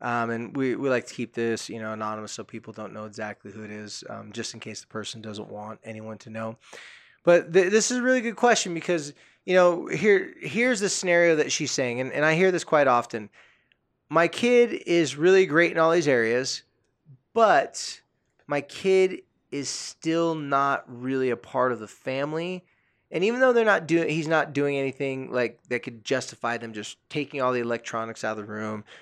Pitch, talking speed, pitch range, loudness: 130 Hz, 205 wpm, 115-165 Hz, -24 LUFS